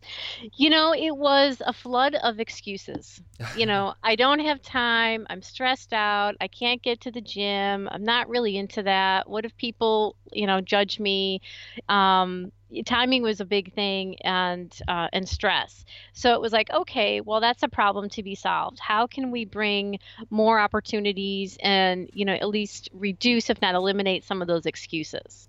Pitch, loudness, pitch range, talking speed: 210 Hz, -24 LUFS, 195-240 Hz, 180 wpm